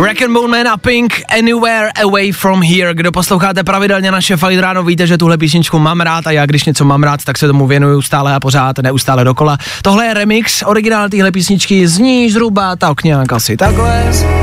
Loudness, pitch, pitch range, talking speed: -10 LUFS, 180 Hz, 145-200 Hz, 200 wpm